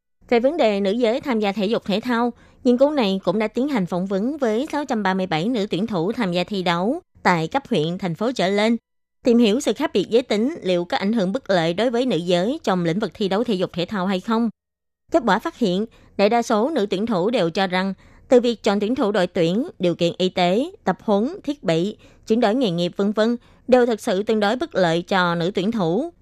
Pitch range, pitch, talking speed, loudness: 185-240 Hz, 210 Hz, 250 wpm, -21 LUFS